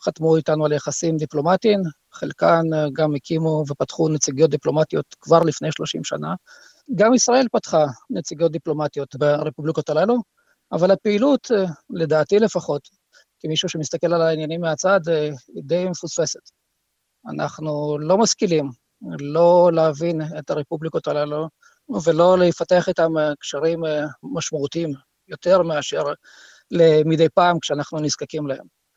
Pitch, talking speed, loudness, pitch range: 160 Hz, 110 wpm, -20 LUFS, 150-180 Hz